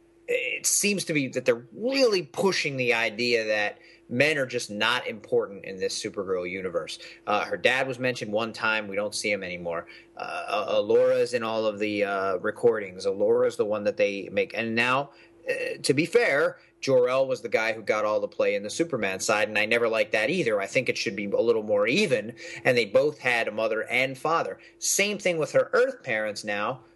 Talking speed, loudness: 210 wpm, -25 LUFS